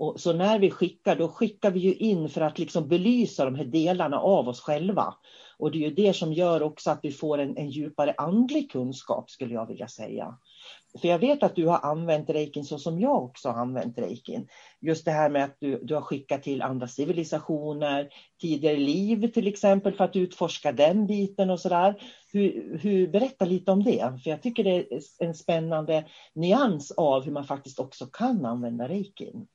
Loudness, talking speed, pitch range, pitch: -26 LUFS, 205 wpm, 150-195 Hz, 165 Hz